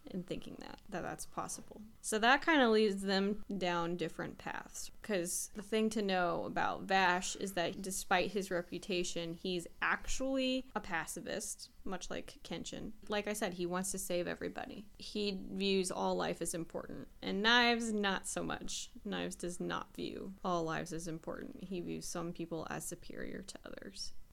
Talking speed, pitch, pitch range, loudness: 170 wpm, 195 Hz, 175-215 Hz, -37 LUFS